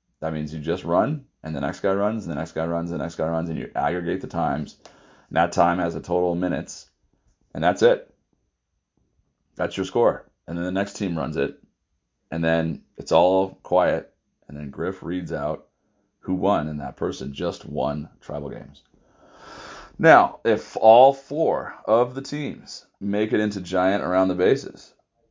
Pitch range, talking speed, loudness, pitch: 80-100 Hz, 185 wpm, -23 LUFS, 90 Hz